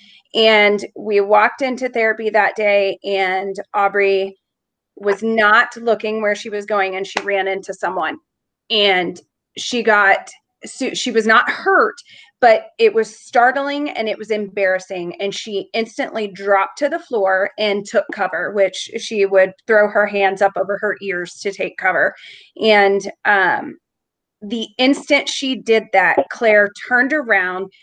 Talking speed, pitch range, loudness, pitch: 150 wpm, 195-235 Hz, -17 LUFS, 210 Hz